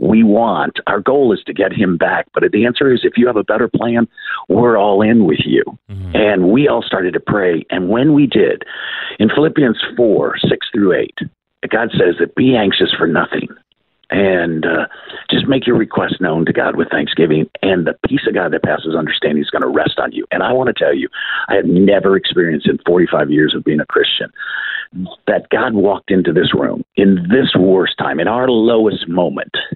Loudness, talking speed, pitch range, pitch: -14 LUFS, 210 wpm, 90-120 Hz, 110 Hz